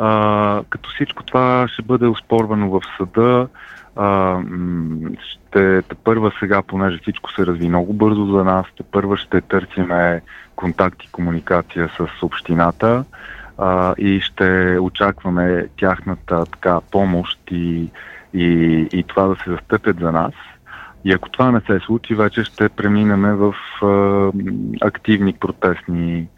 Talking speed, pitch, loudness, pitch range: 135 wpm, 95 Hz, -17 LUFS, 90-105 Hz